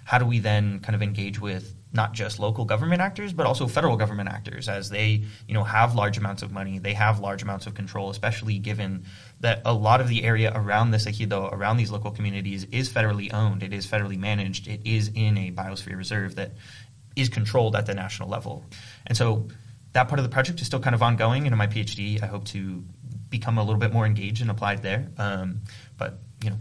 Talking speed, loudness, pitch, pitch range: 230 wpm, -26 LUFS, 110 Hz, 100-115 Hz